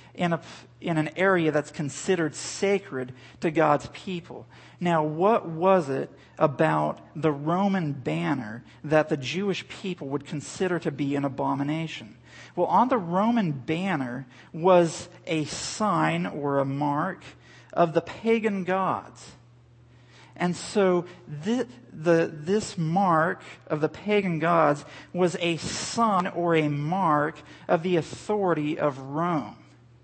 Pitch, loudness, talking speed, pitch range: 160 Hz, -26 LUFS, 130 wpm, 145-185 Hz